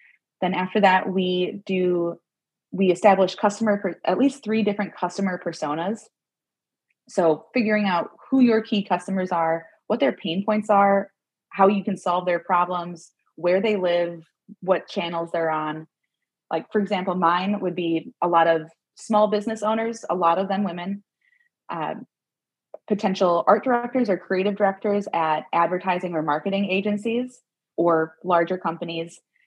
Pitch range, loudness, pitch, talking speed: 170-210 Hz, -23 LUFS, 190 Hz, 150 wpm